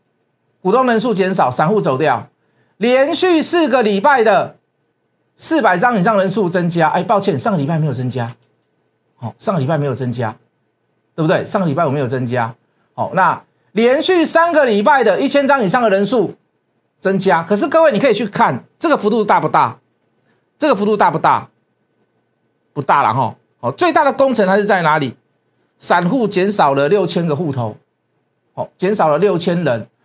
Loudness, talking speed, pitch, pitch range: -15 LUFS, 270 characters per minute, 195 Hz, 150-245 Hz